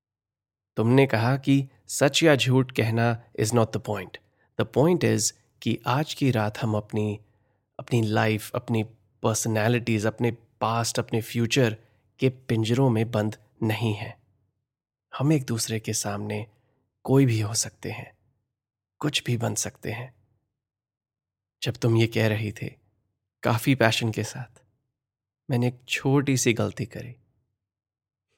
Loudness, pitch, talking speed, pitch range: -25 LUFS, 115 Hz, 135 wpm, 110-125 Hz